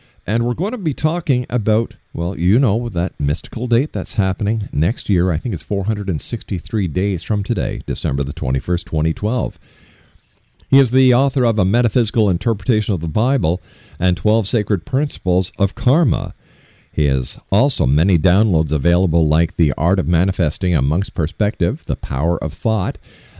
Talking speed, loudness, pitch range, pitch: 160 wpm, -18 LUFS, 85-120 Hz, 100 Hz